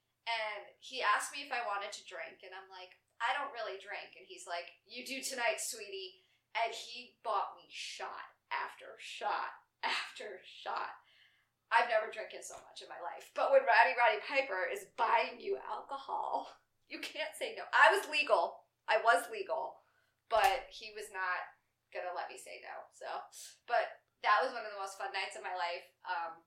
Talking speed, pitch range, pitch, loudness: 190 wpm, 190-270 Hz, 230 Hz, -35 LUFS